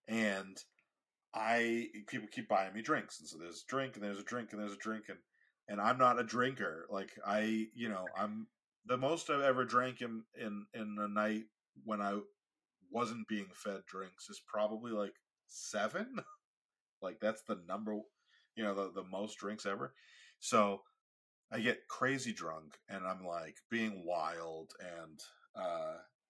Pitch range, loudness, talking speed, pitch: 100-120 Hz, -39 LUFS, 170 wpm, 110 Hz